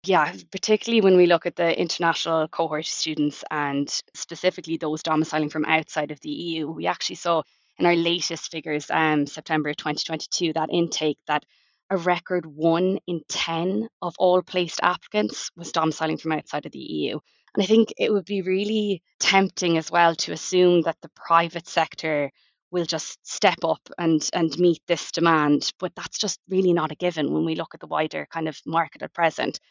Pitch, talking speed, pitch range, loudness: 165 Hz, 190 wpm, 155-180 Hz, -24 LUFS